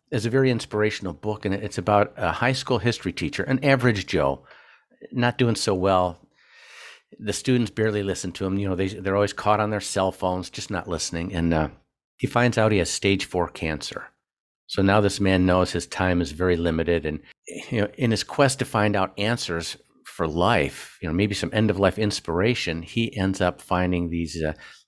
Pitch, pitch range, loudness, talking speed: 100 Hz, 90-110 Hz, -24 LUFS, 205 wpm